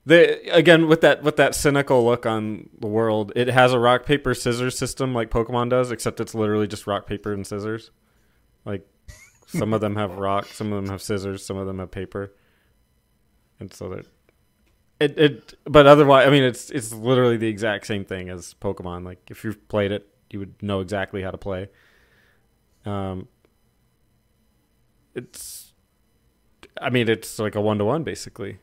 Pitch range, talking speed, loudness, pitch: 100-125 Hz, 180 wpm, -21 LUFS, 110 Hz